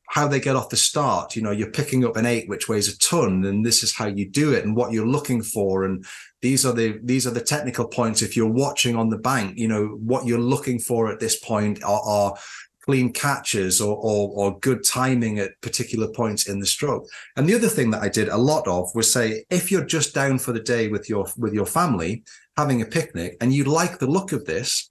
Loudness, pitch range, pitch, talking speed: -22 LUFS, 105-130 Hz, 115 Hz, 245 wpm